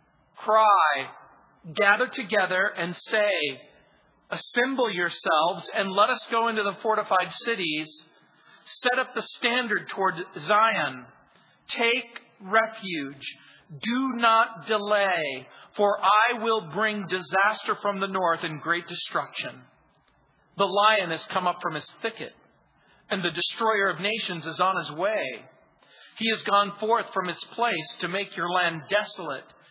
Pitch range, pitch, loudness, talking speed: 175-225 Hz, 200 Hz, -25 LUFS, 135 wpm